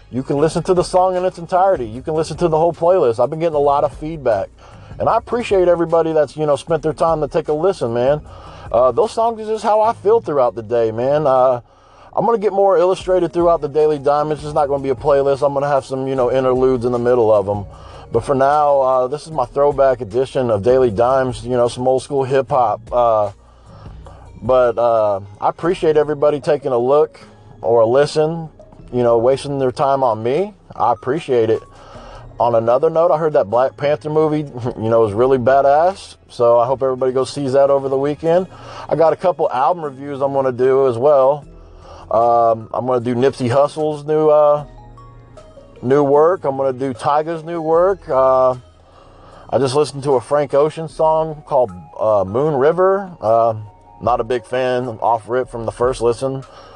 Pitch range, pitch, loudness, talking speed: 120-155 Hz, 135 Hz, -16 LUFS, 205 wpm